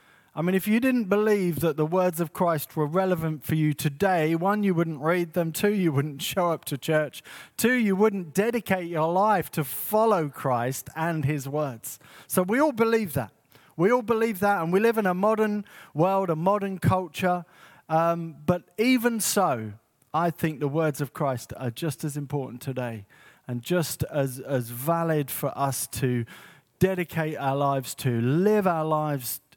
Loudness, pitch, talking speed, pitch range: -26 LUFS, 165 Hz, 180 wpm, 140-190 Hz